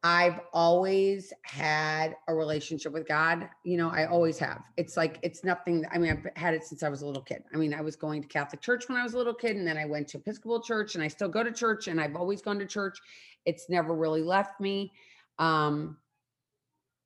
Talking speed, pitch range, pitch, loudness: 230 wpm, 155-195 Hz, 165 Hz, -30 LUFS